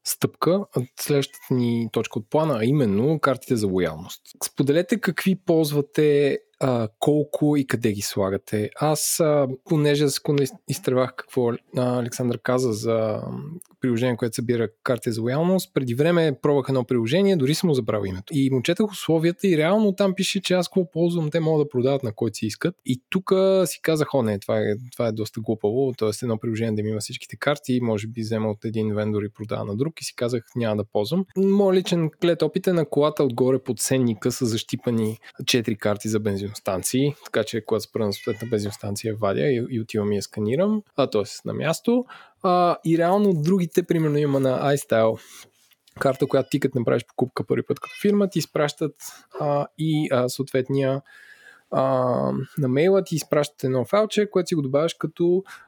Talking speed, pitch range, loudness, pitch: 180 wpm, 115-160 Hz, -23 LUFS, 135 Hz